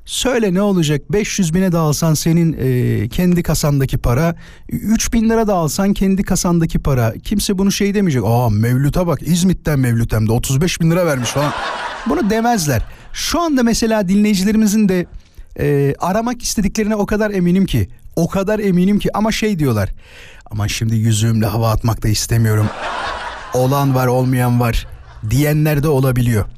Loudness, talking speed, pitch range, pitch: -16 LUFS, 160 wpm, 120-200 Hz, 160 Hz